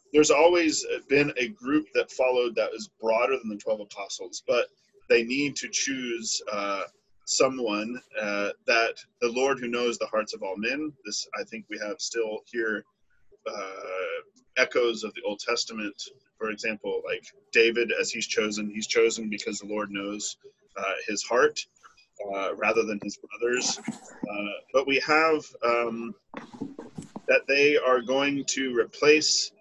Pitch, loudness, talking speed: 135 Hz, -26 LUFS, 155 wpm